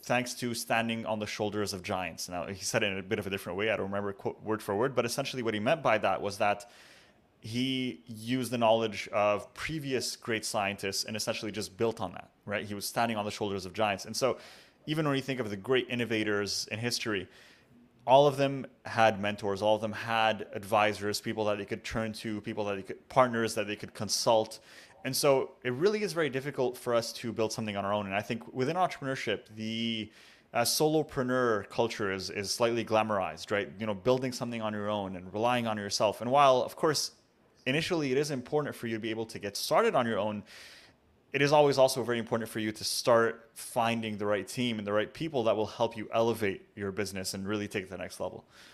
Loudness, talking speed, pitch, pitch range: -31 LUFS, 230 wpm, 110 Hz, 105-125 Hz